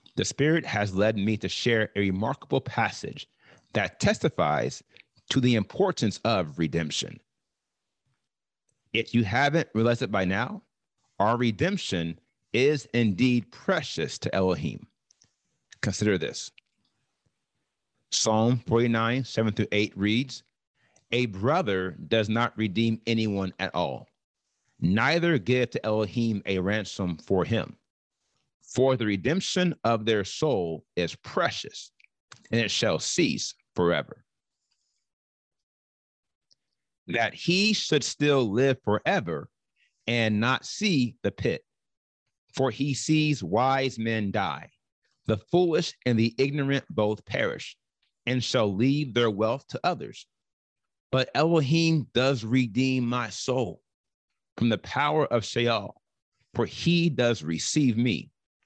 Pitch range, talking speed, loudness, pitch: 105-135 Hz, 120 wpm, -26 LUFS, 120 Hz